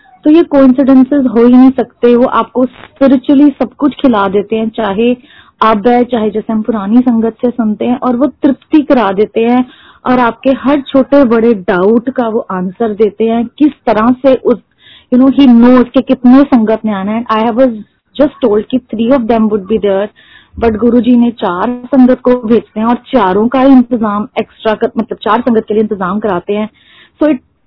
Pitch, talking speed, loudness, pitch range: 240 Hz, 205 wpm, -10 LUFS, 220-260 Hz